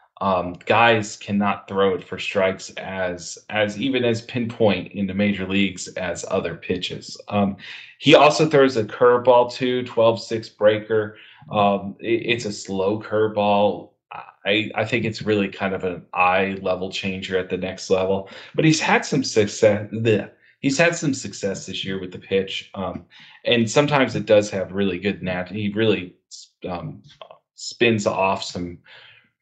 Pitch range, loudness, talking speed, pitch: 95-115 Hz, -21 LUFS, 165 wpm, 105 Hz